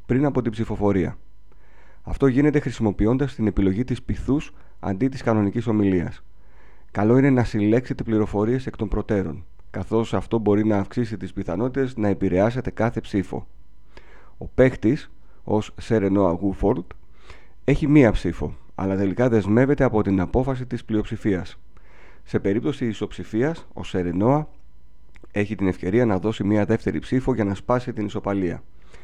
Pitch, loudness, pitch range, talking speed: 105 Hz, -23 LUFS, 95-120 Hz, 140 wpm